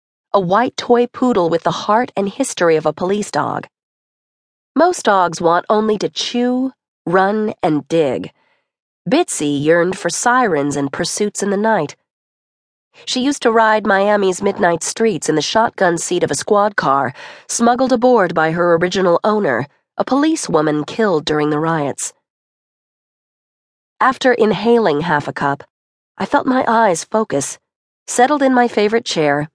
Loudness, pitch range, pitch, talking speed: -16 LUFS, 165-235 Hz, 200 Hz, 150 wpm